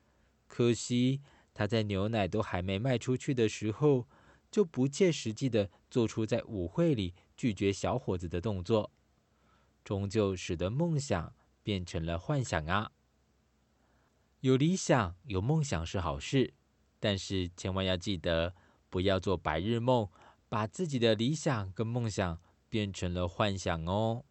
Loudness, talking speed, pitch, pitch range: -32 LUFS, 205 characters per minute, 105 Hz, 95-125 Hz